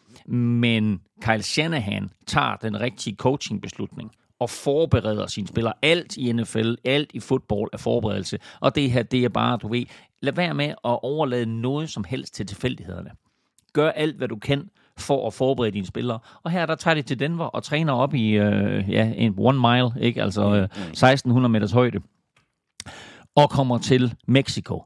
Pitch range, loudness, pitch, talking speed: 110-140 Hz, -23 LUFS, 120 Hz, 175 wpm